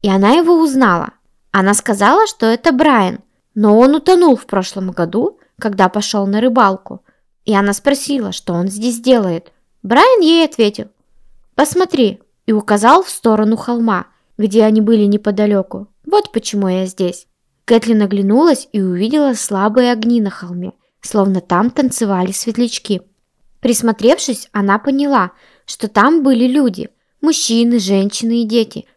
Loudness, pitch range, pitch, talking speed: -13 LUFS, 200-255 Hz, 225 Hz, 135 wpm